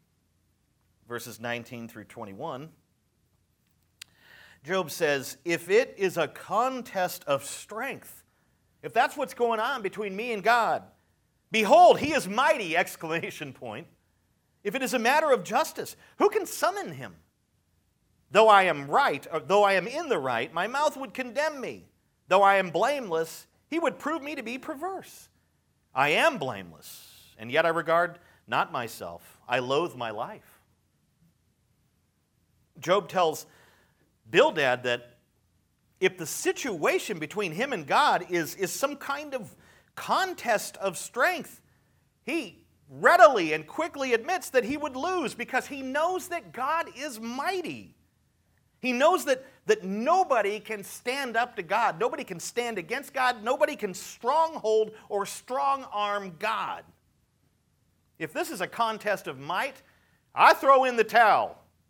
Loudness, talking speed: -26 LUFS, 145 wpm